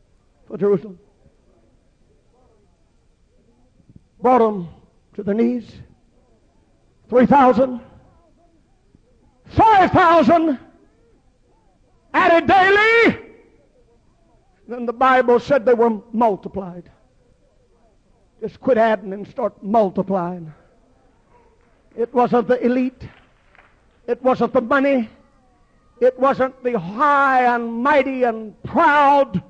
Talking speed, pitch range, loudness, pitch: 85 wpm, 205-275 Hz, -17 LUFS, 245 Hz